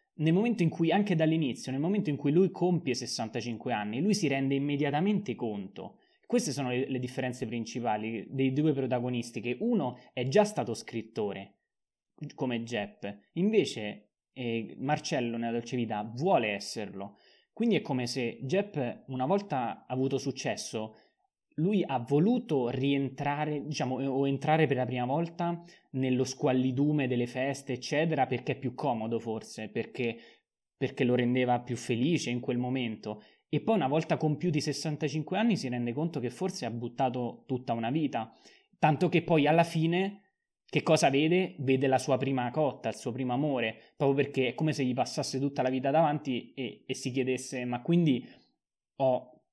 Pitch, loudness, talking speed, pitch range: 135 Hz, -30 LUFS, 165 wpm, 125-155 Hz